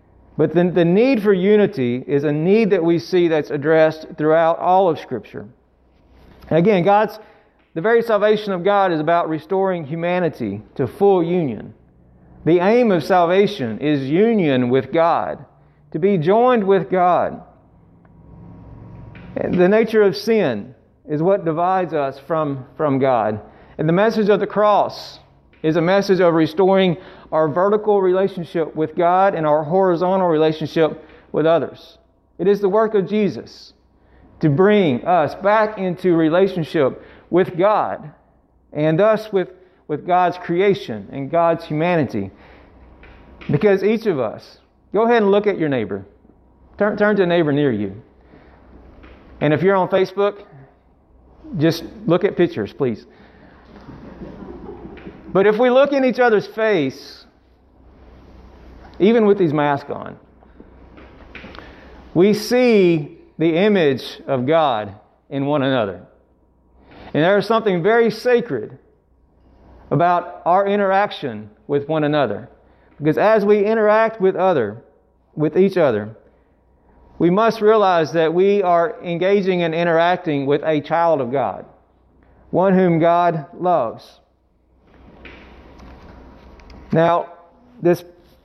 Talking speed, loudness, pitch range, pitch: 130 wpm, -17 LUFS, 135-195 Hz, 170 Hz